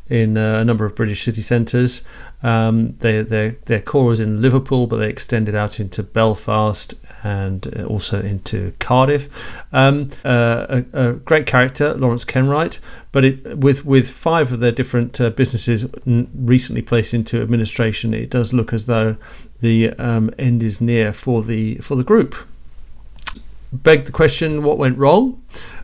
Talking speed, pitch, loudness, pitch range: 155 wpm, 120 Hz, -17 LUFS, 110-130 Hz